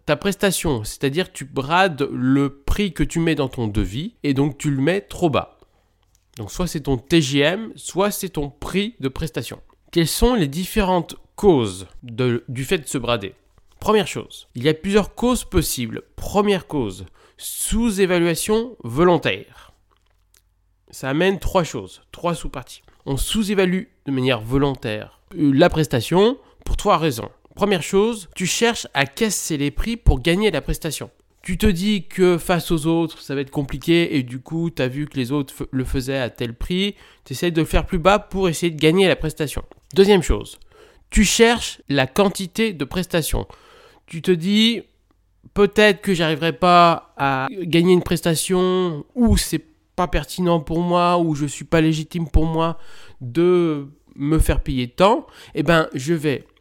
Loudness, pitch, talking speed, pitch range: -20 LUFS, 160 Hz, 170 wpm, 135-185 Hz